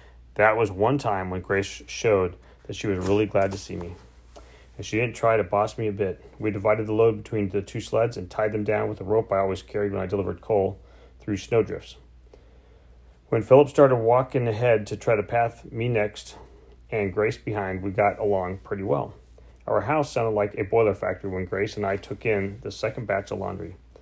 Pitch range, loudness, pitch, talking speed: 95-110 Hz, -25 LUFS, 105 Hz, 210 wpm